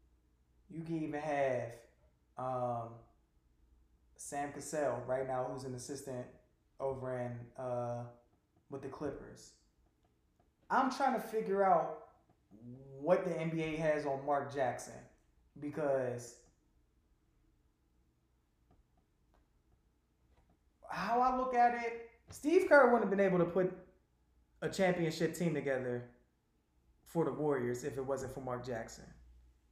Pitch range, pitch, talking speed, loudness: 105-160 Hz, 130 Hz, 115 wpm, -35 LUFS